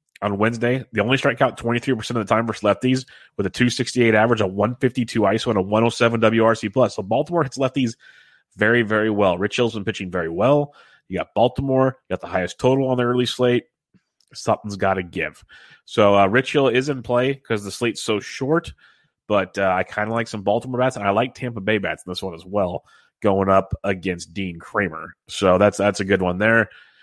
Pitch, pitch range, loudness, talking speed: 110 Hz, 100-125 Hz, -21 LUFS, 230 wpm